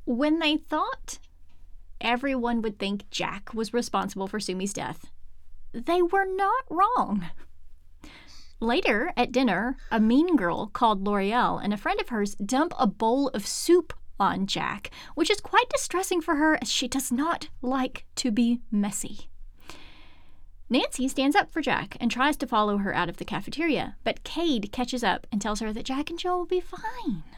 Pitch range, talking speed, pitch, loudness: 195-300 Hz, 170 wpm, 240 Hz, -26 LUFS